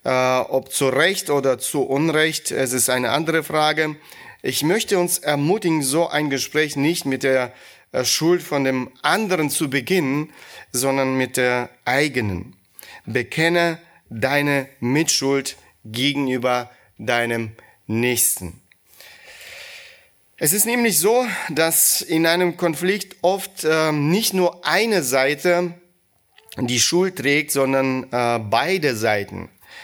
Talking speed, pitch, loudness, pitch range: 115 wpm, 145 Hz, -19 LUFS, 125-170 Hz